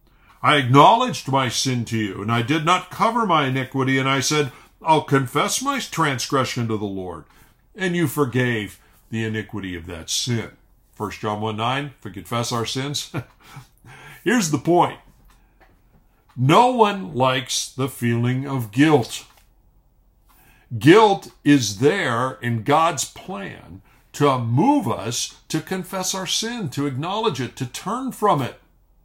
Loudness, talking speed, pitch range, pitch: -20 LUFS, 145 wpm, 115-155 Hz, 135 Hz